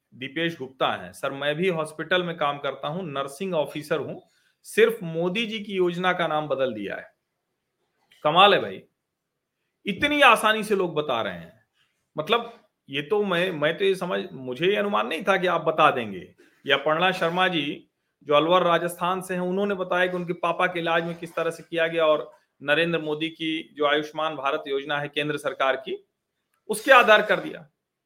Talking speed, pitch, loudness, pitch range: 190 wpm, 170 Hz, -23 LUFS, 150-185 Hz